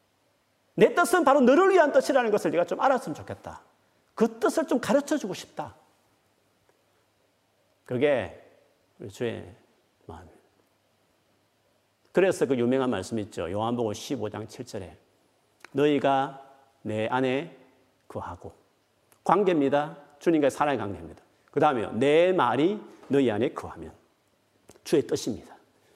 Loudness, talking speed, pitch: -25 LUFS, 260 characters per minute, 140 Hz